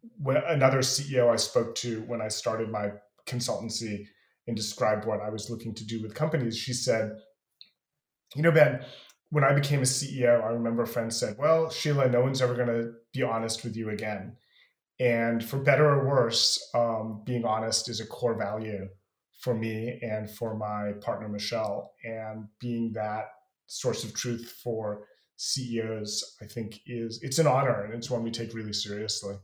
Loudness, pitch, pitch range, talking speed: -28 LUFS, 115 Hz, 110-125 Hz, 180 wpm